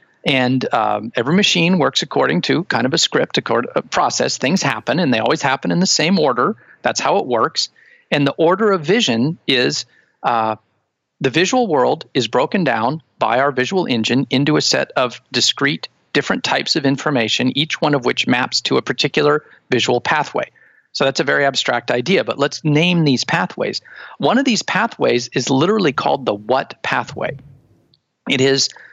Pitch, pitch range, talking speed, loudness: 140 Hz, 125-170 Hz, 185 wpm, -17 LUFS